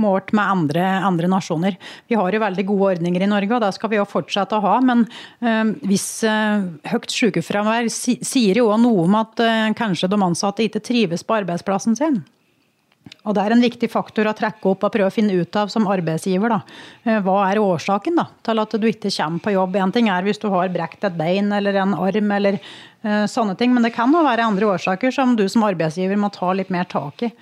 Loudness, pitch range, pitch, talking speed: -19 LUFS, 190-225 Hz, 205 Hz, 230 wpm